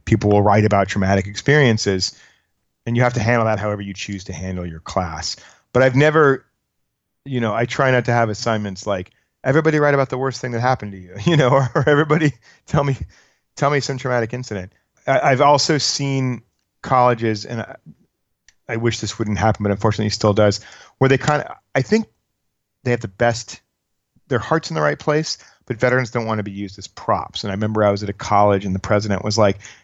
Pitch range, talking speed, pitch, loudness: 100-130 Hz, 215 wpm, 115 Hz, -19 LUFS